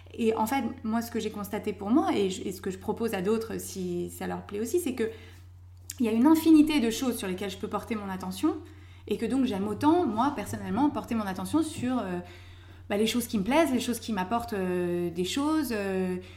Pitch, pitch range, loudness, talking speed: 215 Hz, 185-245 Hz, -28 LUFS, 240 wpm